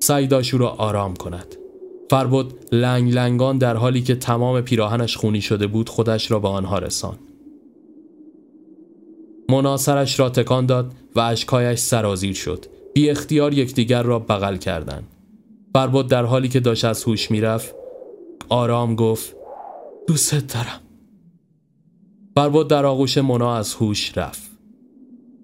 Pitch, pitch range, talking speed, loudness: 130 Hz, 115-185 Hz, 130 wpm, -19 LUFS